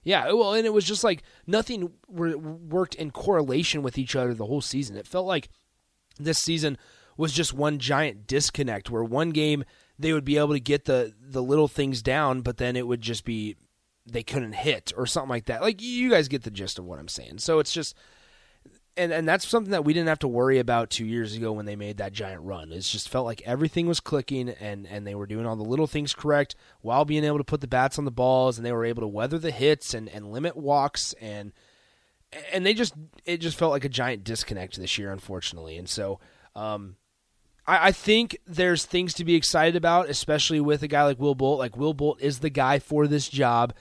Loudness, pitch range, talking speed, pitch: -26 LUFS, 115-155 Hz, 230 wpm, 140 Hz